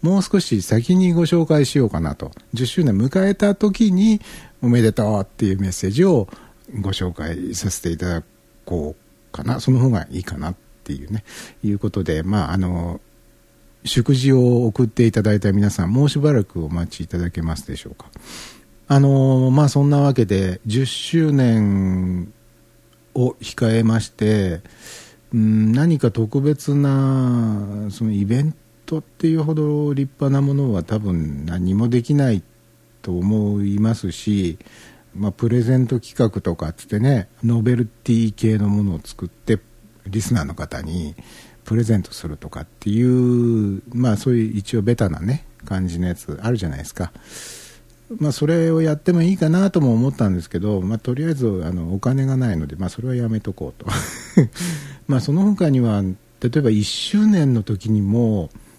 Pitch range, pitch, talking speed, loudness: 100-135 Hz, 115 Hz, 315 characters per minute, -19 LUFS